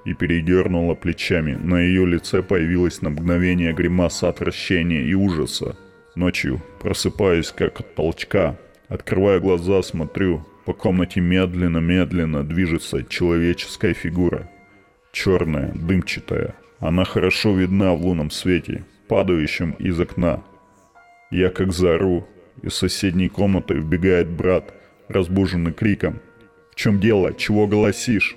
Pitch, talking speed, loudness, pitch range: 90 Hz, 110 wpm, -20 LUFS, 85-95 Hz